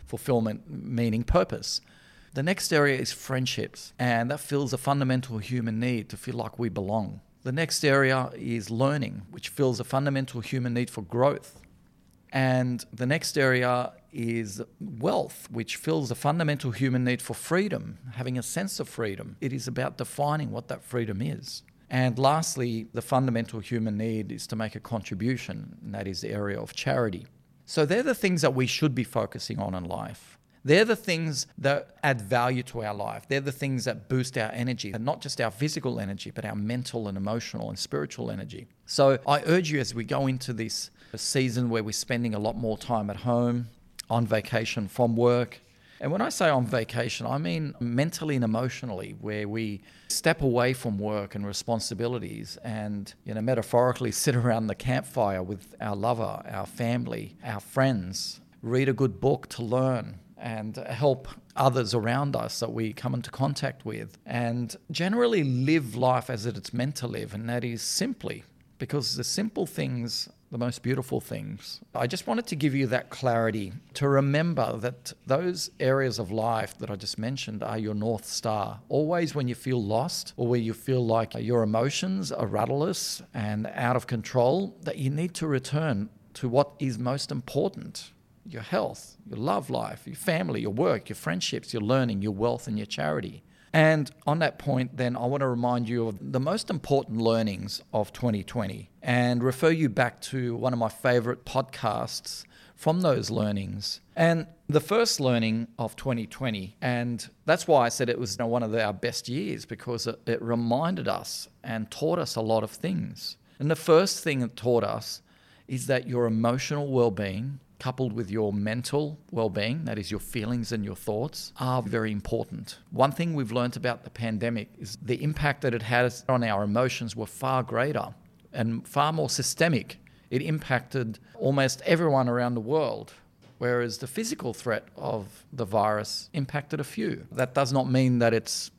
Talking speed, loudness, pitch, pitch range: 180 wpm, -28 LUFS, 125 Hz, 115-135 Hz